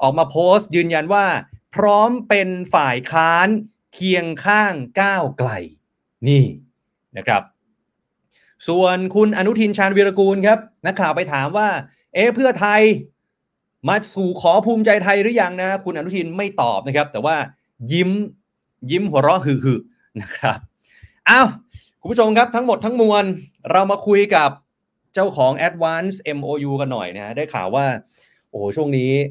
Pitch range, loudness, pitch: 145-205 Hz, -17 LUFS, 185 Hz